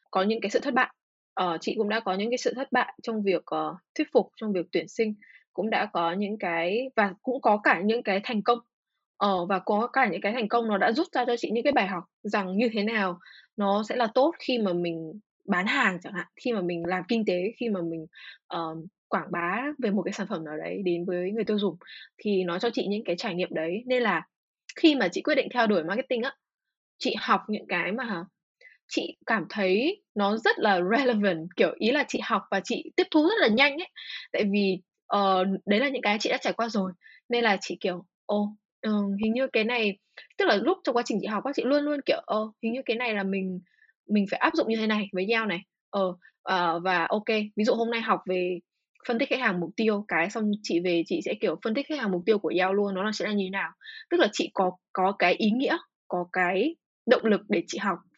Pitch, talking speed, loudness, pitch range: 210 Hz, 255 wpm, -27 LUFS, 190-245 Hz